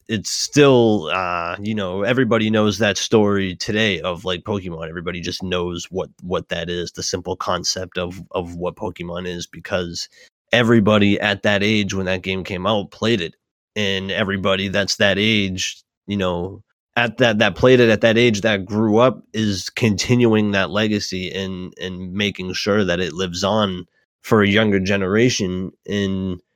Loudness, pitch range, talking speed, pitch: -19 LUFS, 90-110 Hz, 170 wpm, 100 Hz